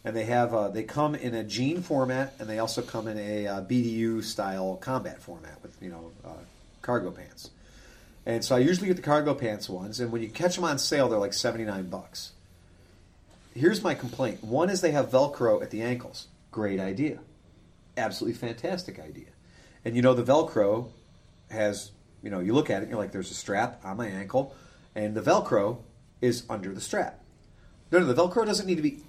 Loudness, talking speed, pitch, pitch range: -28 LUFS, 210 wpm, 115 Hz, 100-130 Hz